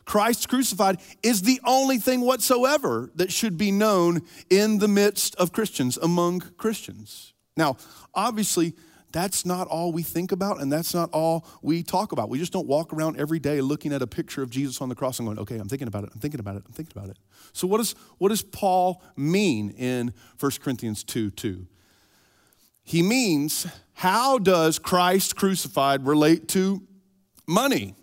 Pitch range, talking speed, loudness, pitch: 135-195 Hz, 180 wpm, -24 LUFS, 170 Hz